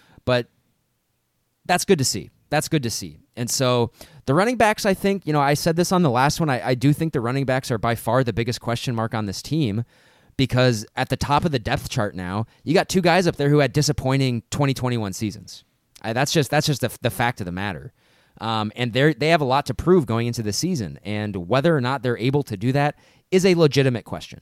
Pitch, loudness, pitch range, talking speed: 130 Hz, -21 LUFS, 115-150 Hz, 240 wpm